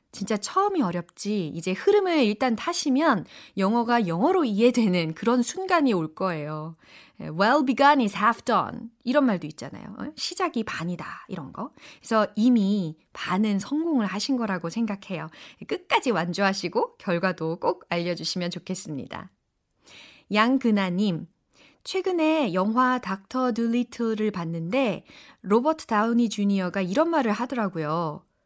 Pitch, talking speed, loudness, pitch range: 215 Hz, 320 characters per minute, -25 LUFS, 180-260 Hz